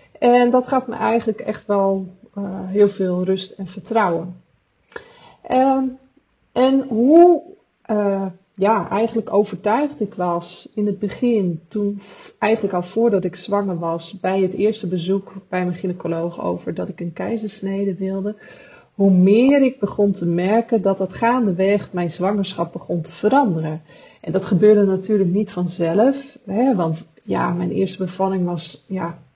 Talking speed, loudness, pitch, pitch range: 150 wpm, -19 LUFS, 195 Hz, 180-225 Hz